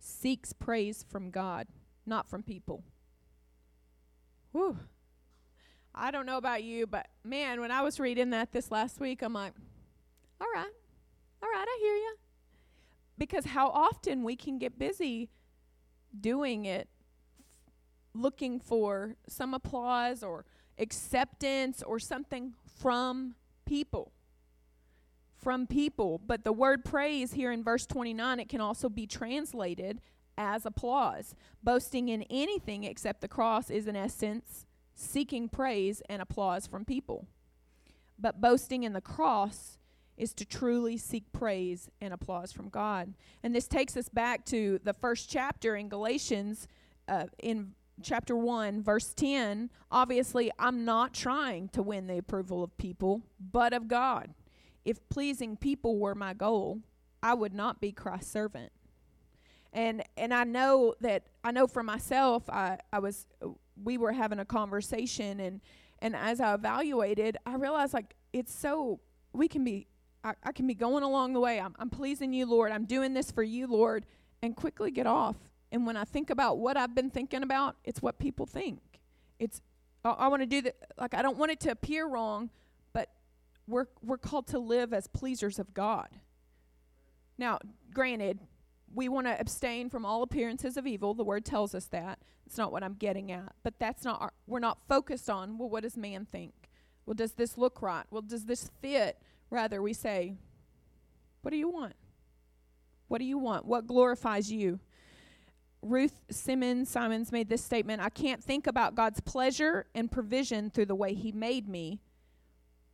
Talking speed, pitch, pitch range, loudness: 165 wpm, 230 Hz, 195-255 Hz, -33 LUFS